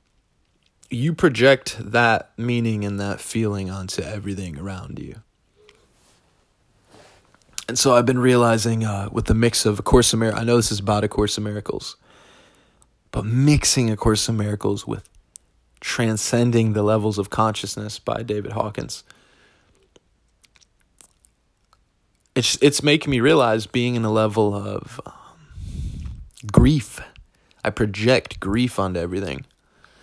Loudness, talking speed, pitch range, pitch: -20 LUFS, 130 wpm, 100-120 Hz, 110 Hz